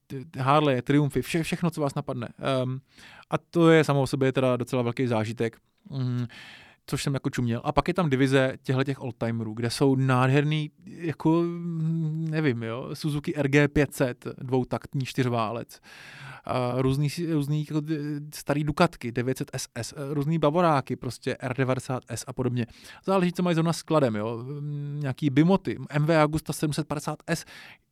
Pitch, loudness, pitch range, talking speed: 140 Hz, -26 LUFS, 130-155 Hz, 140 wpm